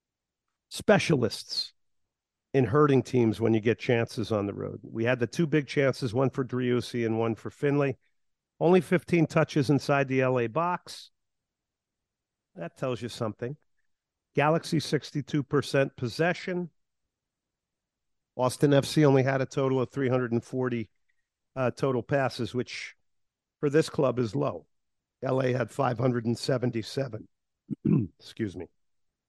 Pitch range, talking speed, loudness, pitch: 120-145 Hz, 125 wpm, -28 LUFS, 130 Hz